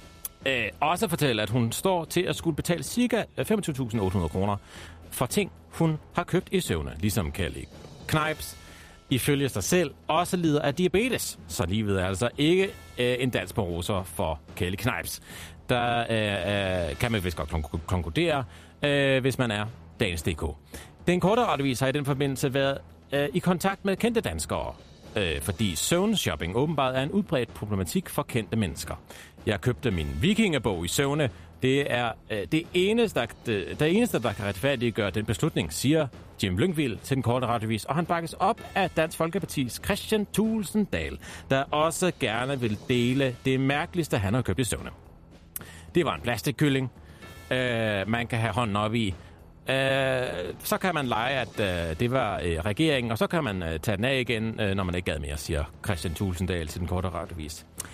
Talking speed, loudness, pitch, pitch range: 170 wpm, -27 LUFS, 120 Hz, 90-150 Hz